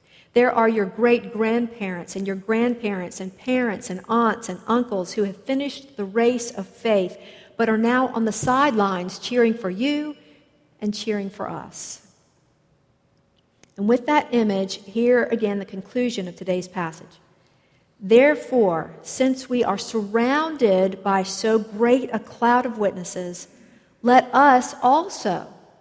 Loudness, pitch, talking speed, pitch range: -22 LUFS, 225 Hz, 140 wpm, 195-245 Hz